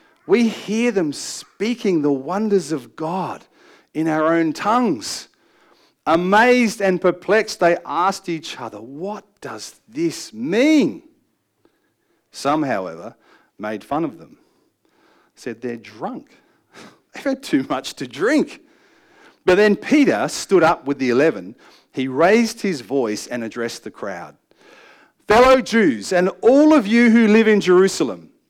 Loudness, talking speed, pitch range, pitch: -18 LUFS, 135 wpm, 160-265 Hz, 210 Hz